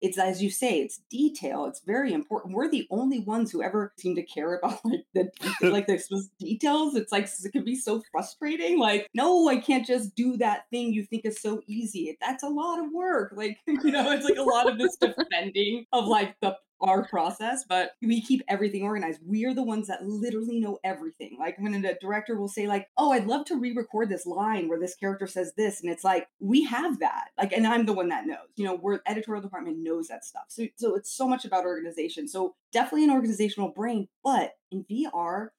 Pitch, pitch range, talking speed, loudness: 215 Hz, 195-255 Hz, 225 wpm, -28 LUFS